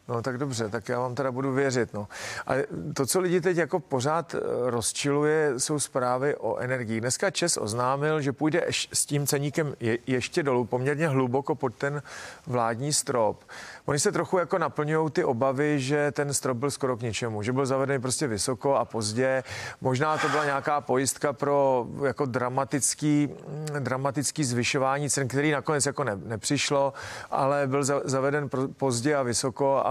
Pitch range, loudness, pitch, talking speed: 130-150 Hz, -27 LUFS, 140 Hz, 165 wpm